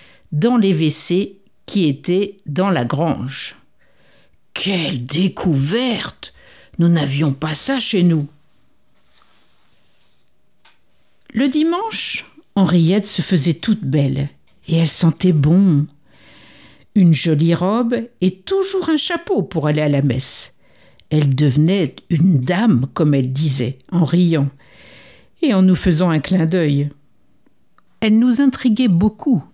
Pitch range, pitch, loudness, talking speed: 150-200 Hz, 175 Hz, -17 LUFS, 120 wpm